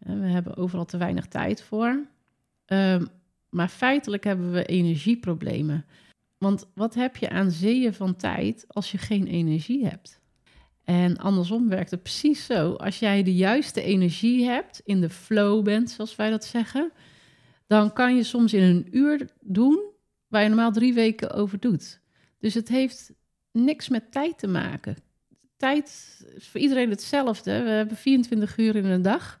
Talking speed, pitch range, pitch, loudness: 165 wpm, 185-245 Hz, 215 Hz, -24 LUFS